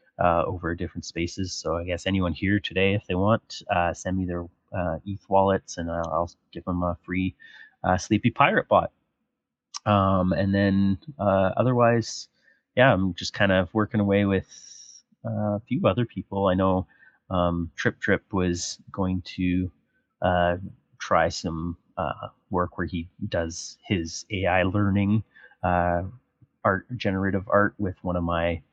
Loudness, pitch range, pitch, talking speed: -25 LUFS, 90-100 Hz, 95 Hz, 160 wpm